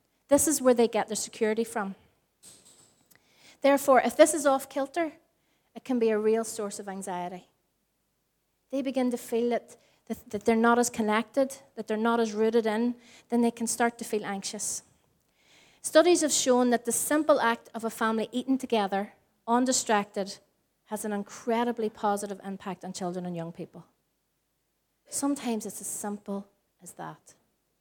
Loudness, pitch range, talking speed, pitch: -27 LUFS, 205-250 Hz, 160 wpm, 230 Hz